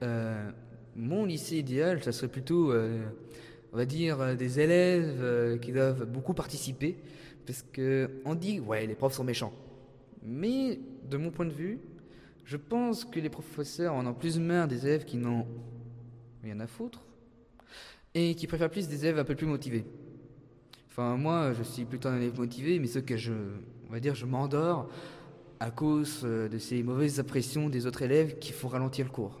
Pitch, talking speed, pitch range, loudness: 130 Hz, 180 wpm, 120-155 Hz, -32 LUFS